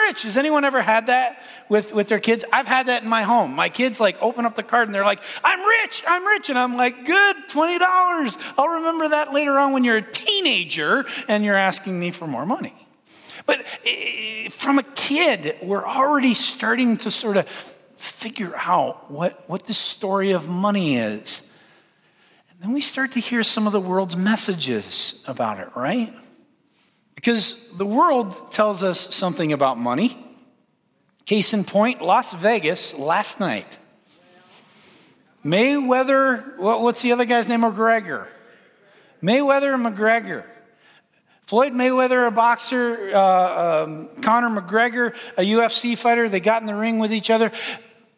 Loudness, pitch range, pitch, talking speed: -20 LUFS, 210-265 Hz, 235 Hz, 160 wpm